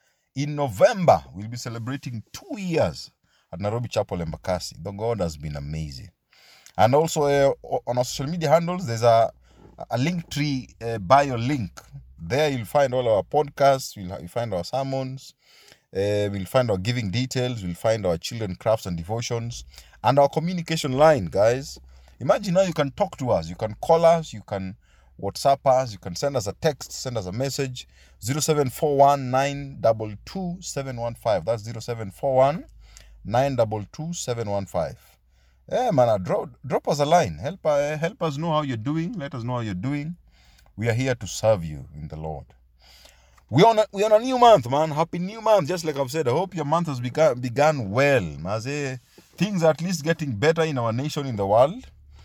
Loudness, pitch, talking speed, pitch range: -23 LUFS, 130 Hz, 185 wpm, 100-150 Hz